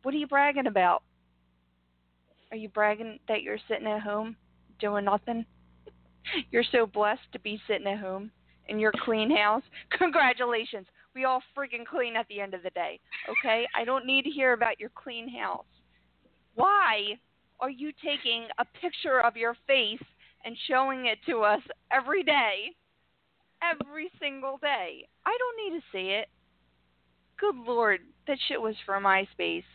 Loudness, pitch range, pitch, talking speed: -28 LUFS, 200-270 Hz, 225 Hz, 160 wpm